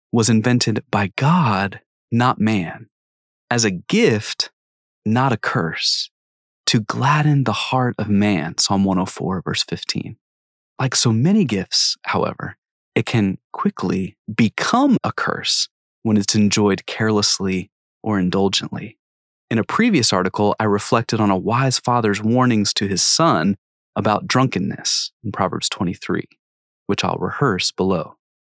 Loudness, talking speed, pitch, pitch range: -19 LUFS, 130 wpm, 105 Hz, 95-115 Hz